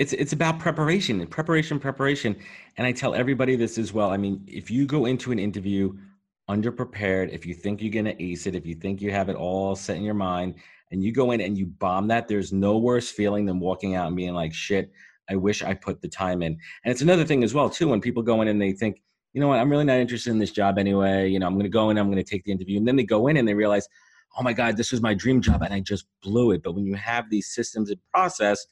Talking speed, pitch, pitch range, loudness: 275 wpm, 105 Hz, 95-120 Hz, -24 LUFS